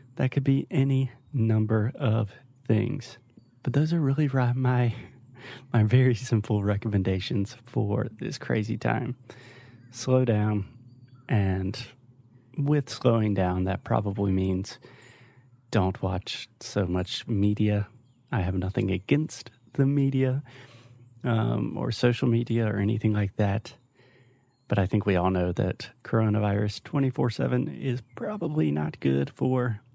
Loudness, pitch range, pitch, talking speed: -27 LUFS, 105-125 Hz, 120 Hz, 130 wpm